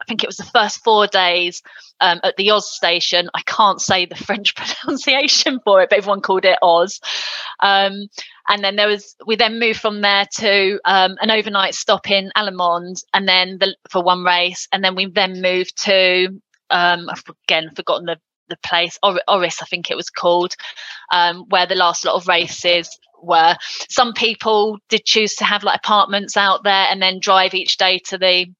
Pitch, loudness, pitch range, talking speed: 195 Hz, -16 LUFS, 180-210 Hz, 195 wpm